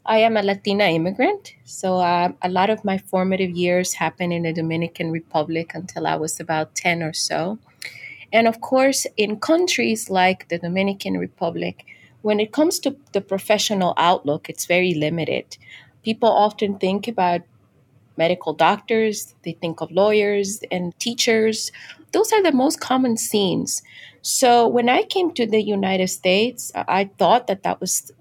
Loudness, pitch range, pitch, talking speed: -20 LUFS, 170-225 Hz, 195 Hz, 160 wpm